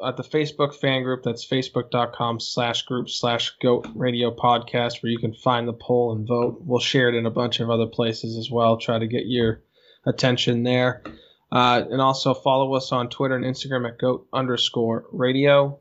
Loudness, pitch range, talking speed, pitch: -22 LUFS, 120-130 Hz, 195 wpm, 125 Hz